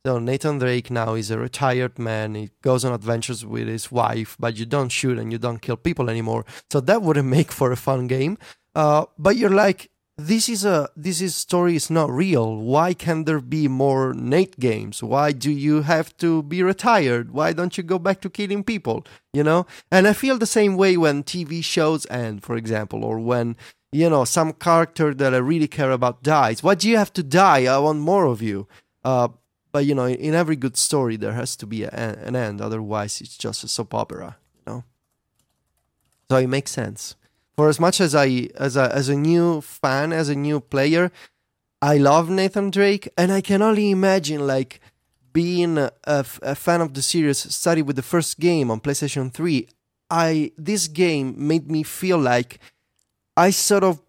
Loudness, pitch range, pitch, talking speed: -21 LUFS, 125-170 Hz, 145 Hz, 200 wpm